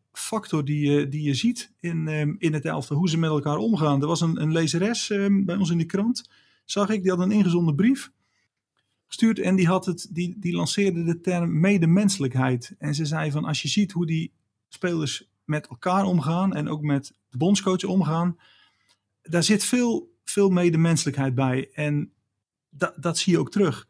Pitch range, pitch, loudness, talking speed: 150-195 Hz, 170 Hz, -24 LUFS, 185 wpm